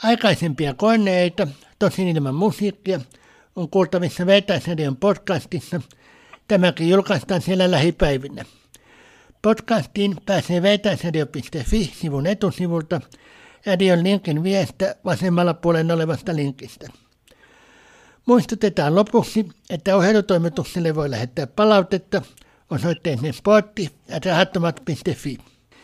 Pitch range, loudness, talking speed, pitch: 160-195 Hz, -20 LUFS, 85 wpm, 180 Hz